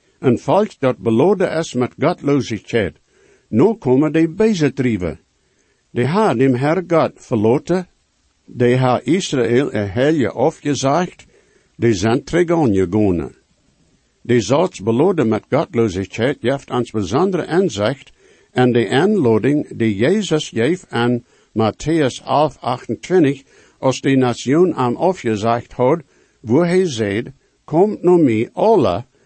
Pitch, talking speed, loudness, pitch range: 130 Hz, 120 wpm, -17 LUFS, 115-160 Hz